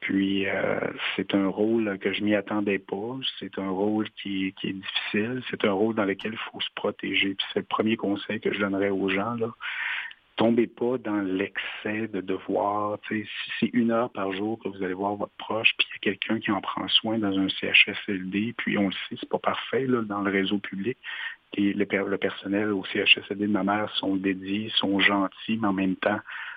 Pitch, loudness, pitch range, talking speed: 100 Hz, -26 LUFS, 95-110 Hz, 215 wpm